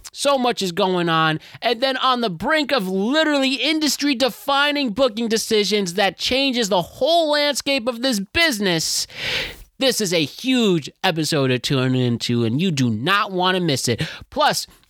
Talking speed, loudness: 165 wpm, -19 LUFS